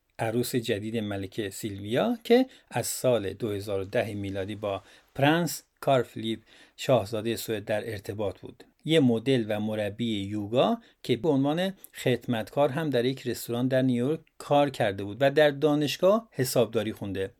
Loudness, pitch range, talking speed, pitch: -28 LUFS, 110-145 Hz, 140 wpm, 120 Hz